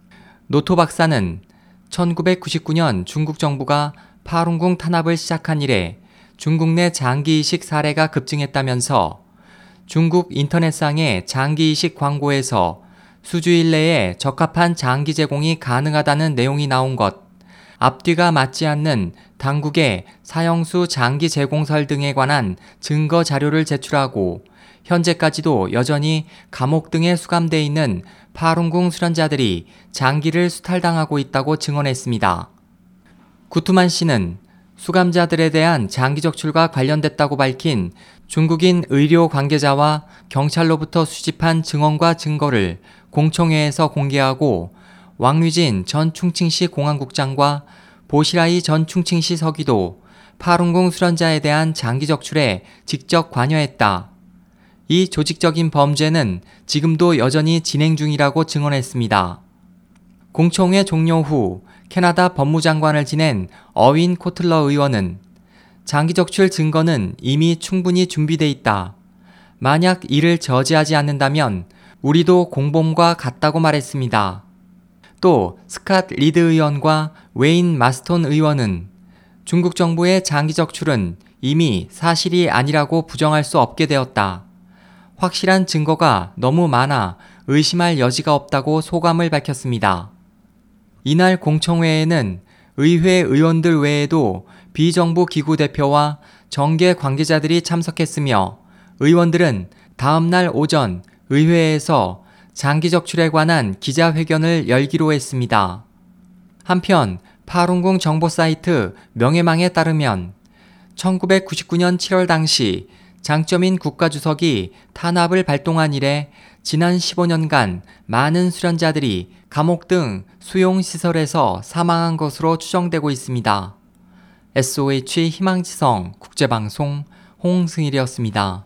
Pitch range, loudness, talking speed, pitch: 140-175 Hz, -17 LUFS, 265 characters per minute, 160 Hz